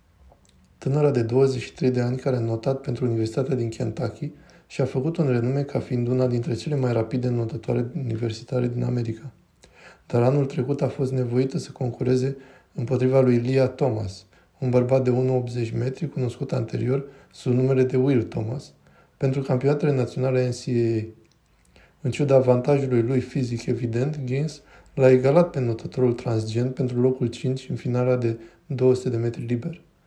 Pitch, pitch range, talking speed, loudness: 130 Hz, 120-135 Hz, 155 wpm, -24 LUFS